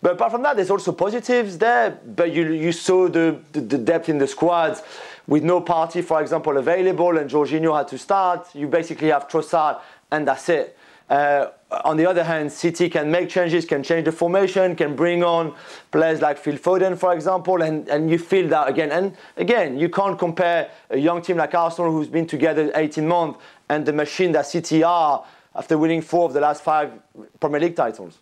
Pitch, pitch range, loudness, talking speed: 165 Hz, 155-180 Hz, -20 LUFS, 205 wpm